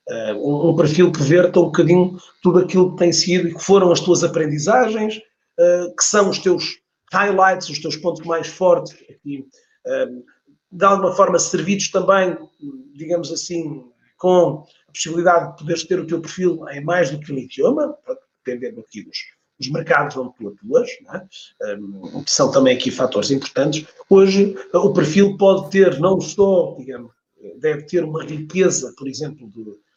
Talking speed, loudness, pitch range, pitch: 160 wpm, -17 LUFS, 155-190 Hz, 175 Hz